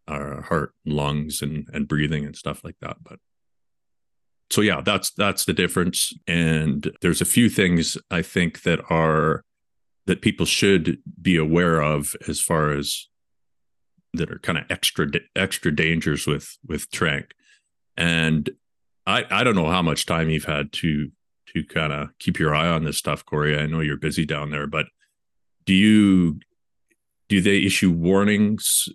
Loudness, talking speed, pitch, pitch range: -22 LUFS, 165 wpm, 80 Hz, 75-85 Hz